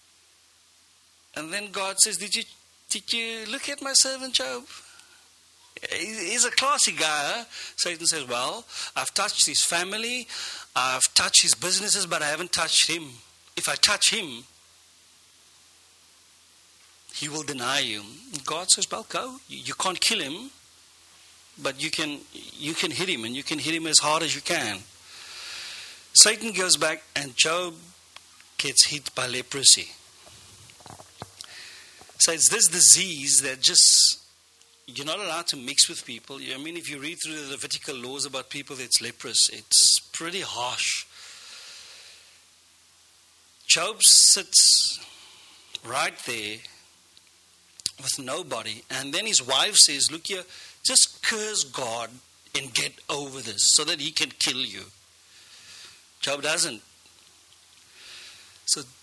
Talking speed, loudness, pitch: 135 wpm, -21 LUFS, 140 Hz